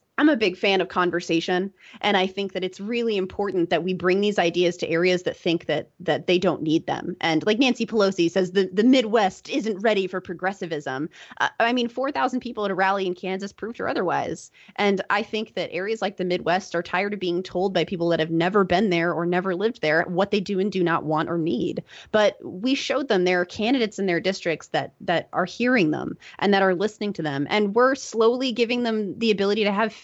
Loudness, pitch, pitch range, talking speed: -23 LUFS, 190 Hz, 175-215 Hz, 230 wpm